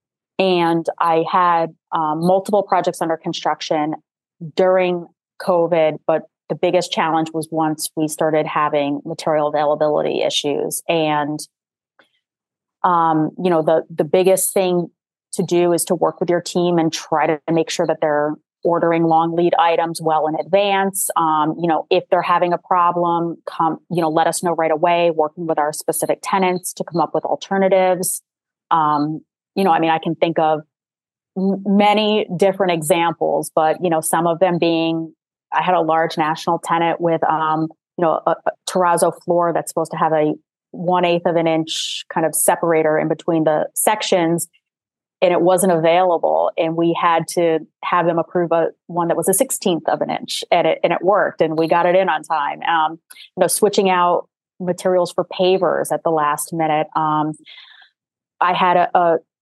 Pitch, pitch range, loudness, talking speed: 170 Hz, 160-180 Hz, -18 LUFS, 180 wpm